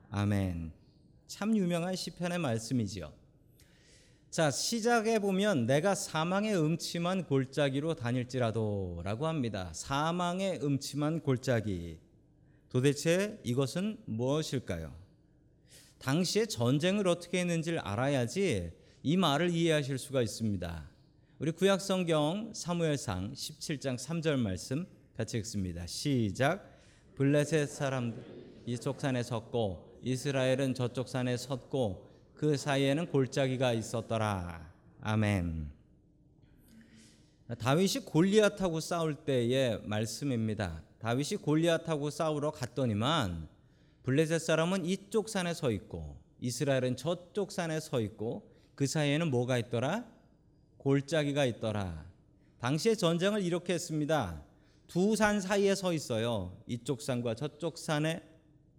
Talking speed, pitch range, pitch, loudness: 260 characters per minute, 120-165 Hz, 140 Hz, -32 LUFS